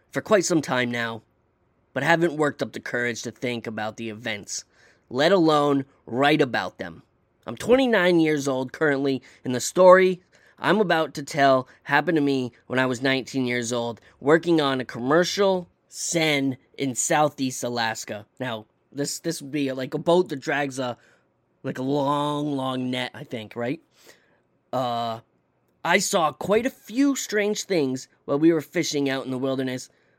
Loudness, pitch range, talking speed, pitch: -23 LUFS, 120-160 Hz, 170 wpm, 135 Hz